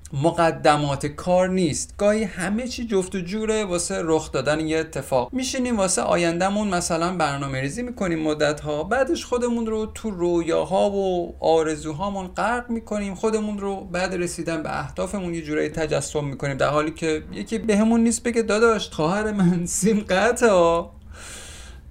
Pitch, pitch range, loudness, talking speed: 180 Hz, 155-215 Hz, -23 LUFS, 150 wpm